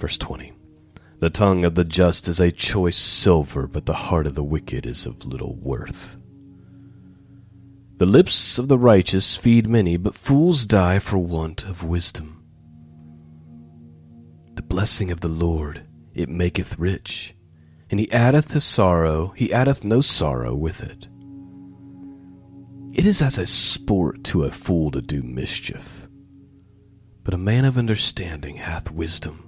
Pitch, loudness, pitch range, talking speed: 95 Hz, -20 LUFS, 80-115 Hz, 145 wpm